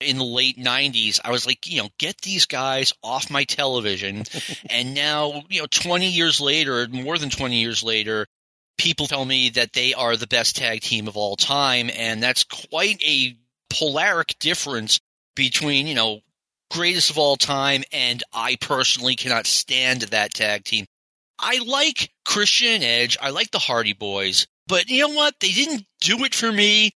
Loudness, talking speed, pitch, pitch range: -19 LUFS, 180 wpm, 135 Hz, 120-165 Hz